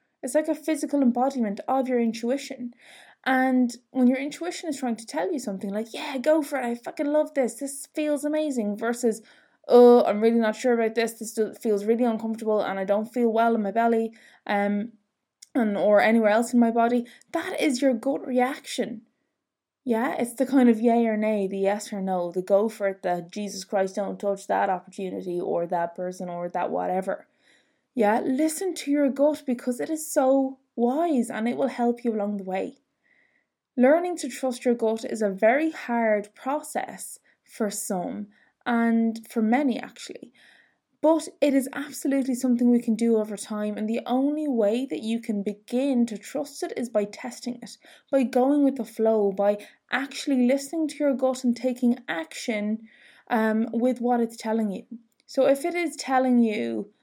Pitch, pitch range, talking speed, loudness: 240 Hz, 215-275 Hz, 185 wpm, -25 LUFS